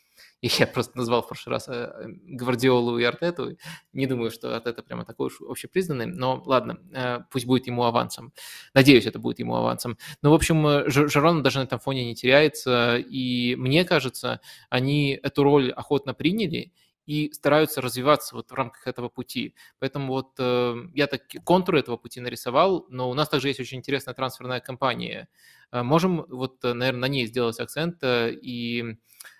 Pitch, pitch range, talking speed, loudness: 130 Hz, 125-145 Hz, 160 wpm, -24 LUFS